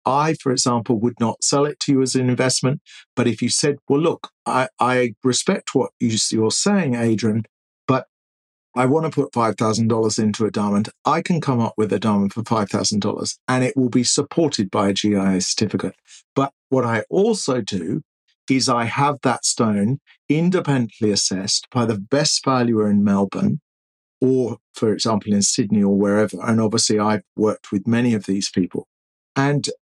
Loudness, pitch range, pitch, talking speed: -20 LUFS, 105-130 Hz, 115 Hz, 185 wpm